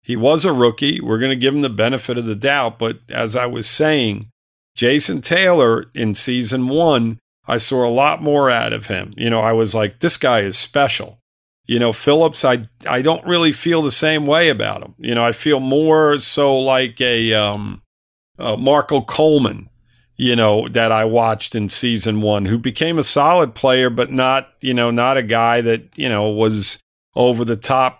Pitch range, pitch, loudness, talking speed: 115-135 Hz, 120 Hz, -16 LUFS, 200 wpm